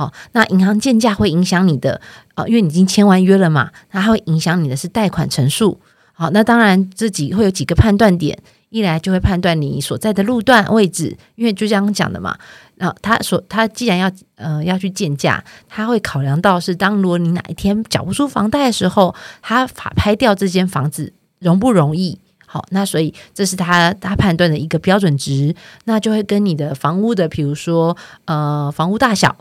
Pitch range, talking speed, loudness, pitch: 165-210 Hz, 305 characters per minute, -15 LUFS, 185 Hz